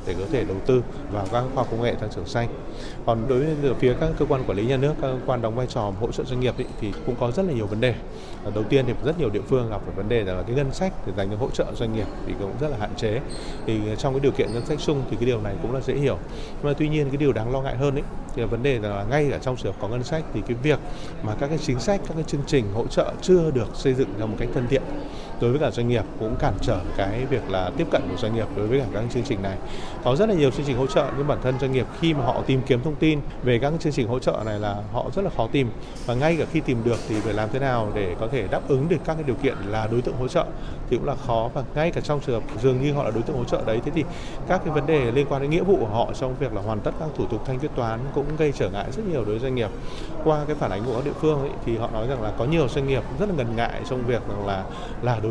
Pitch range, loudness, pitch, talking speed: 110-145 Hz, -25 LUFS, 130 Hz, 320 wpm